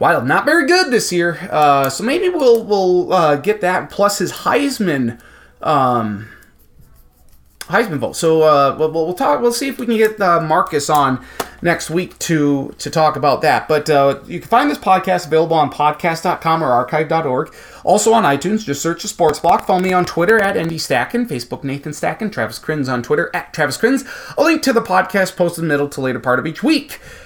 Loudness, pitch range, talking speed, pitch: -16 LUFS, 150-210 Hz, 205 wpm, 170 Hz